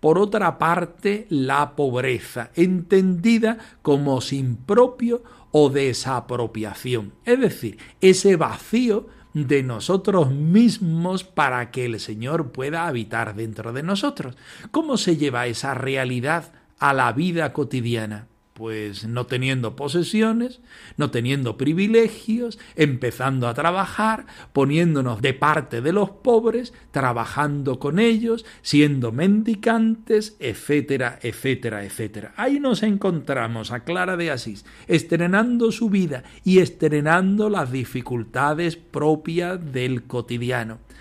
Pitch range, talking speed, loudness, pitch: 125-200 Hz, 115 wpm, -22 LUFS, 150 Hz